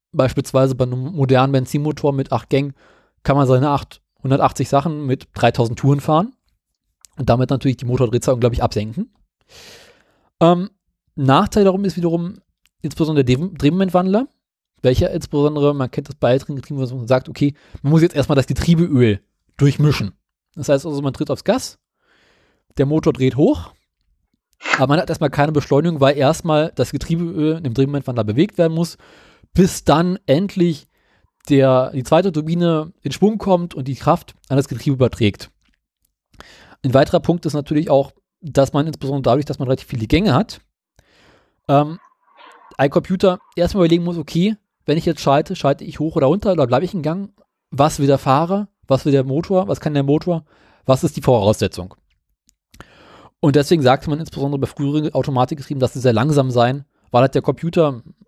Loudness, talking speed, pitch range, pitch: -18 LUFS, 165 wpm, 130-165 Hz, 145 Hz